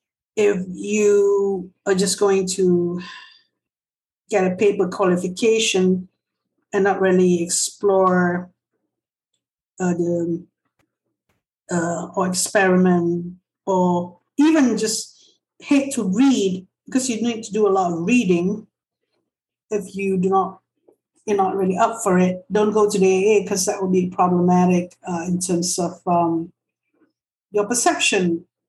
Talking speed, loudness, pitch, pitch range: 130 wpm, -19 LUFS, 190 Hz, 180-205 Hz